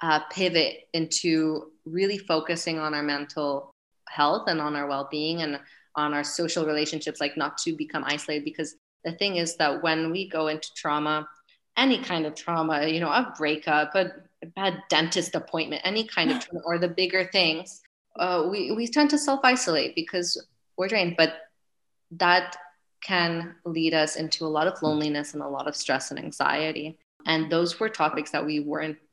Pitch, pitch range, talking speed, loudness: 160 Hz, 150-180 Hz, 175 wpm, -26 LUFS